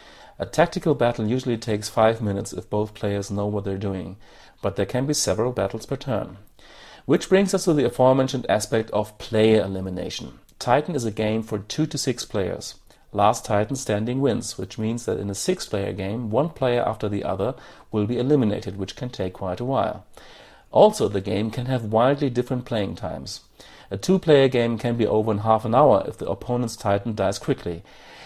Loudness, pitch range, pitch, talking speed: -23 LUFS, 100-130 Hz, 110 Hz, 195 wpm